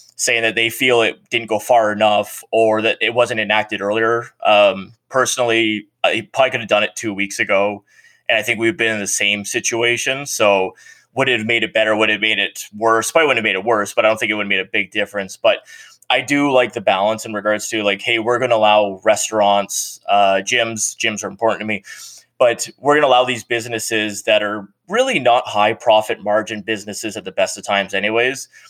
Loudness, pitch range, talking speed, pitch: -17 LUFS, 105-115 Hz, 230 wpm, 110 Hz